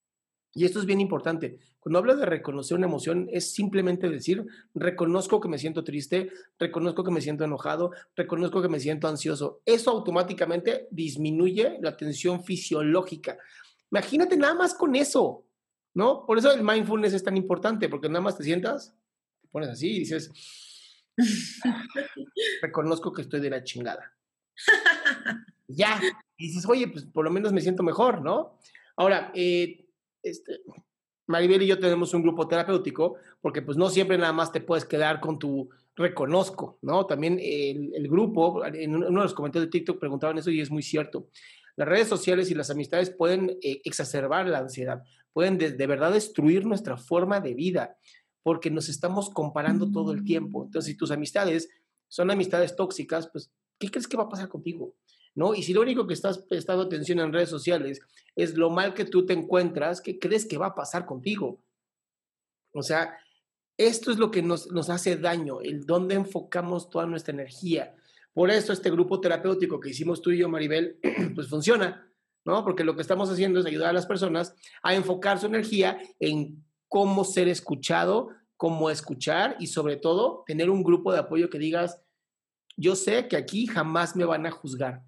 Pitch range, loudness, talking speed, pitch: 160-195 Hz, -26 LUFS, 180 wpm, 175 Hz